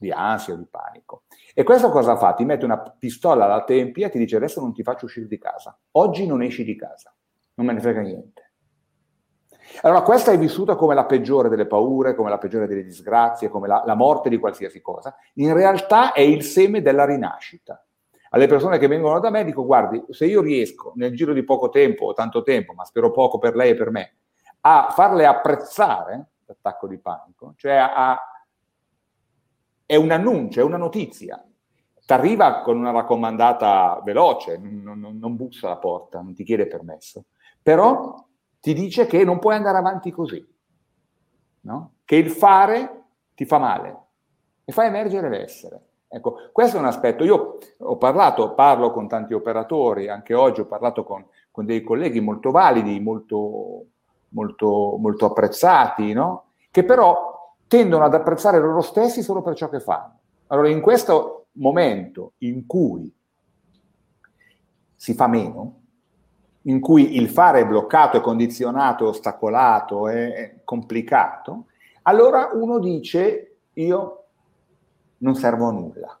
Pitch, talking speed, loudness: 150 Hz, 165 wpm, -18 LUFS